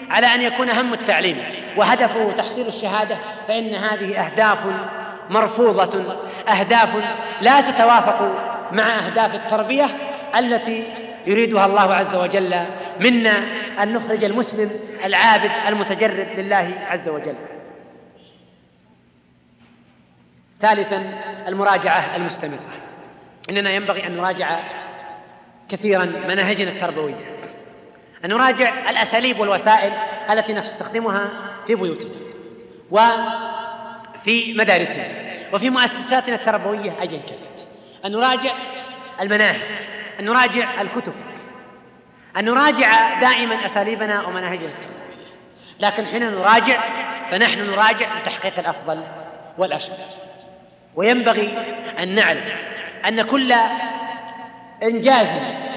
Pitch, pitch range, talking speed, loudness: 215 Hz, 195-230 Hz, 90 wpm, -18 LUFS